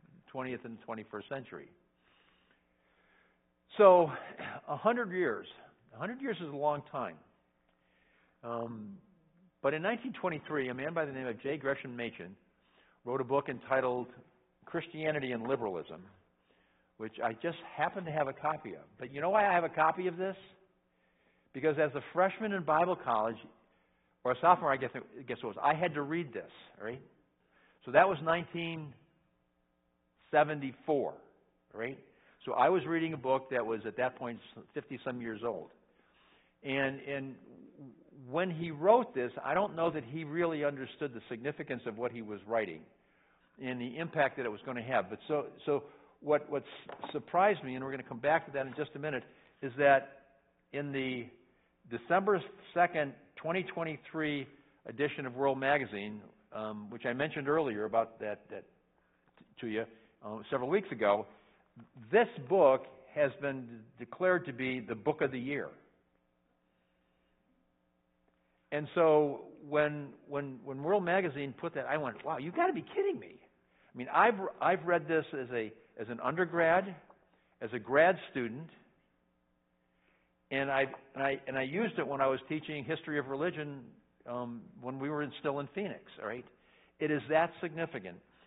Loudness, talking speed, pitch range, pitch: -34 LUFS, 165 wpm, 115-160 Hz, 140 Hz